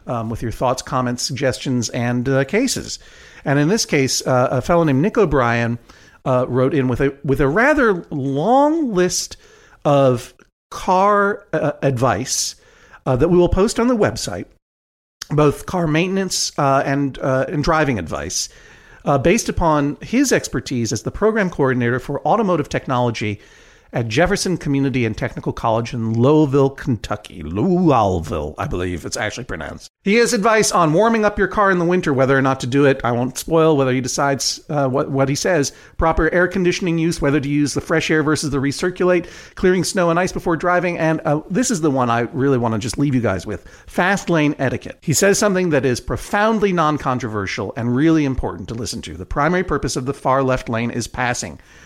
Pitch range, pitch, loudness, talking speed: 125-175 Hz, 140 Hz, -18 LUFS, 190 wpm